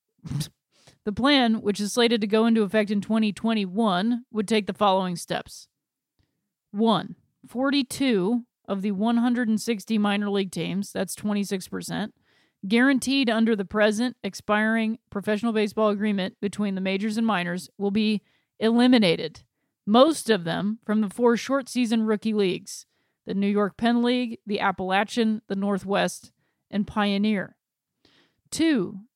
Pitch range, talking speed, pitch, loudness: 200-230 Hz, 130 wpm, 215 Hz, -24 LUFS